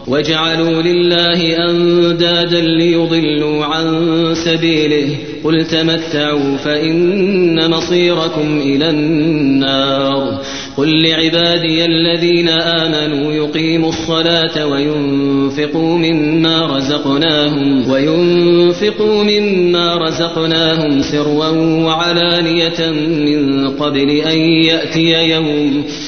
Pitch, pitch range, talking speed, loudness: 160 Hz, 150-165 Hz, 65 wpm, -12 LUFS